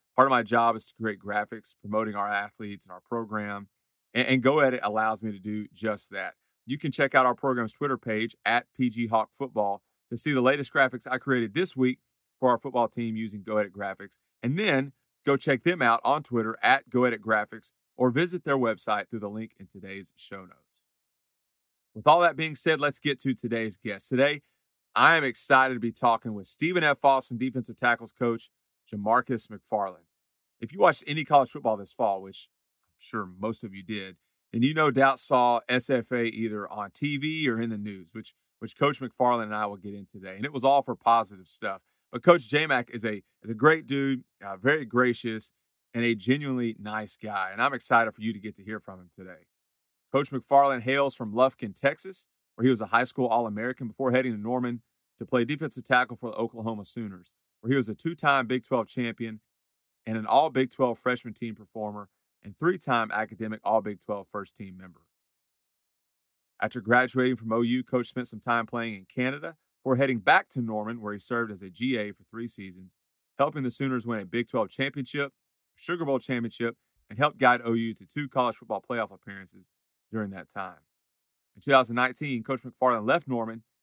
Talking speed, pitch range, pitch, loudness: 200 wpm, 110-130 Hz, 120 Hz, -27 LUFS